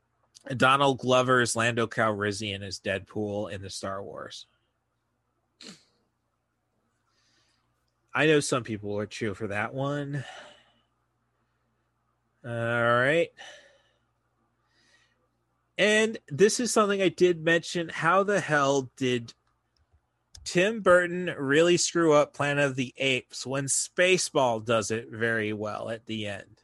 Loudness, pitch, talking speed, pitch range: -26 LUFS, 125 Hz, 115 wpm, 115-150 Hz